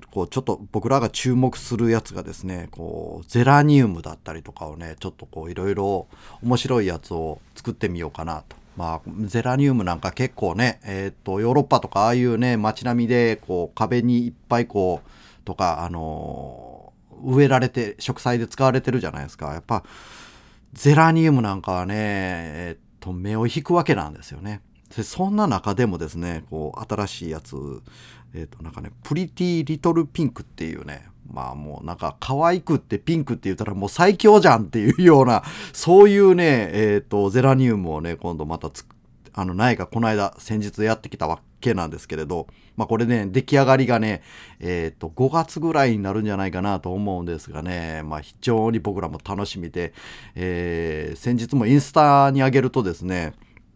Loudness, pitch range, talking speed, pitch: -21 LUFS, 85-130 Hz, 380 characters per minute, 110 Hz